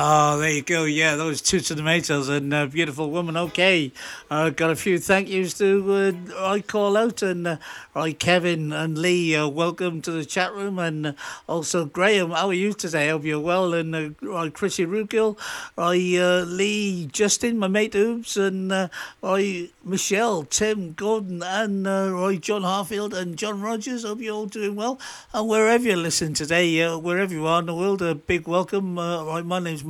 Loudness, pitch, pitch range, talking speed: -23 LUFS, 180 Hz, 165-200 Hz, 200 wpm